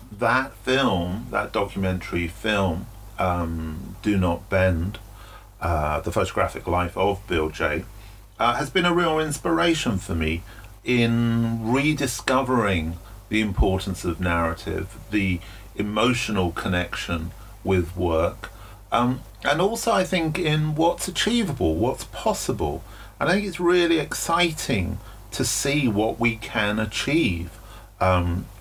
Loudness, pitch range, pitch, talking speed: -24 LUFS, 90-130 Hz, 105 Hz, 120 wpm